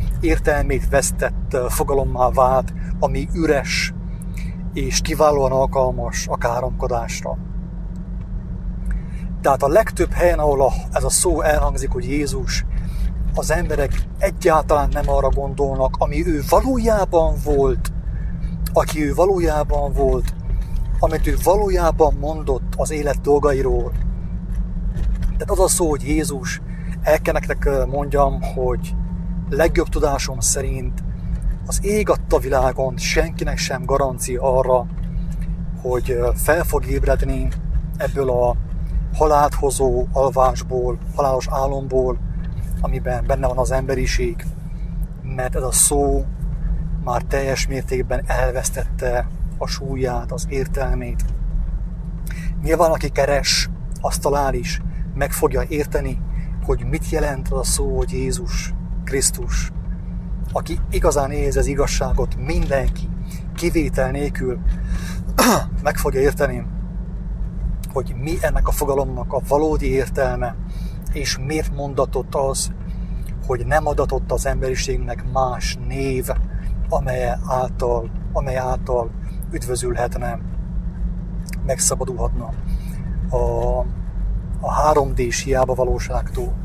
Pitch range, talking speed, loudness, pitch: 125-155 Hz, 105 wpm, -21 LUFS, 135 Hz